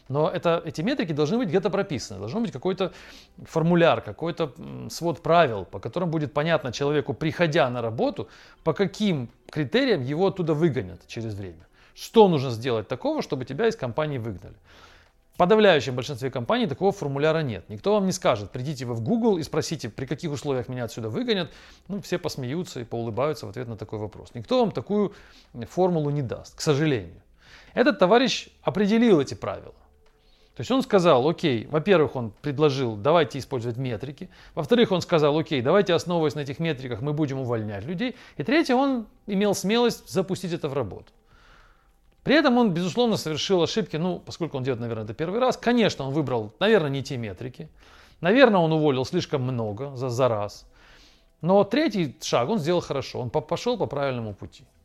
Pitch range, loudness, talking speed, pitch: 130-185 Hz, -24 LUFS, 175 wpm, 155 Hz